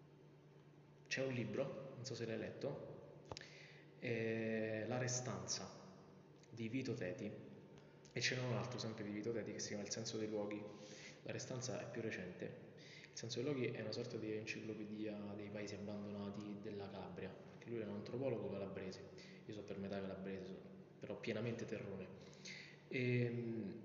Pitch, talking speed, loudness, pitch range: 110 Hz, 155 wpm, -46 LUFS, 105-120 Hz